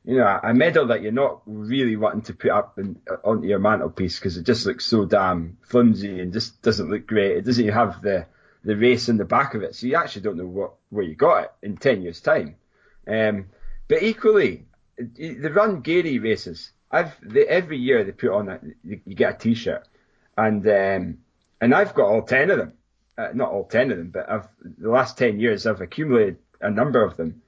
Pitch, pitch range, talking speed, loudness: 110 Hz, 100-125 Hz, 215 wpm, -21 LUFS